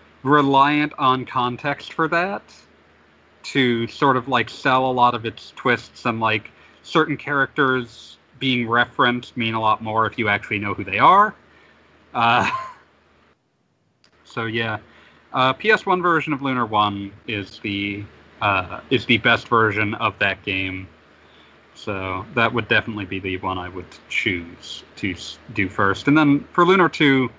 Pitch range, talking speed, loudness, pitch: 100-135 Hz, 150 wpm, -20 LUFS, 115 Hz